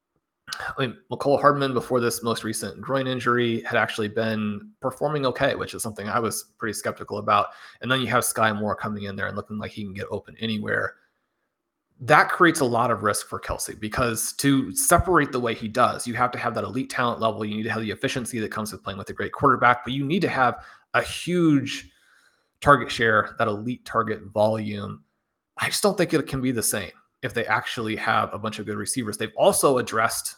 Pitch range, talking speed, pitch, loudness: 105-130 Hz, 220 wpm, 115 Hz, -24 LUFS